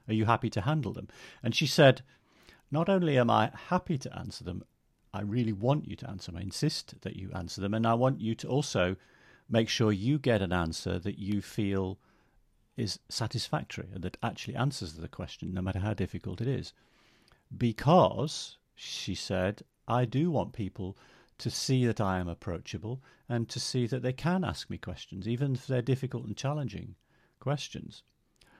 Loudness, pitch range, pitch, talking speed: -31 LUFS, 100-130 Hz, 115 Hz, 185 wpm